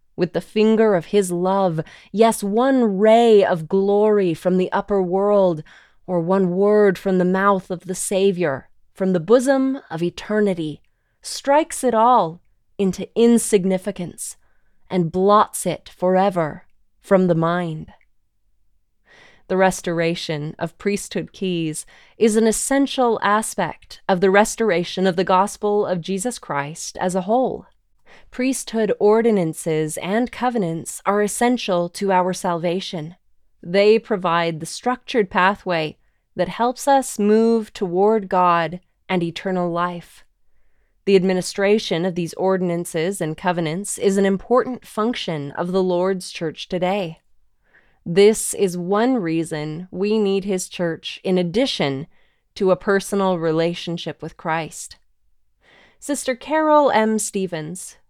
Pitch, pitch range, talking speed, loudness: 190 Hz, 175-215 Hz, 125 wpm, -20 LUFS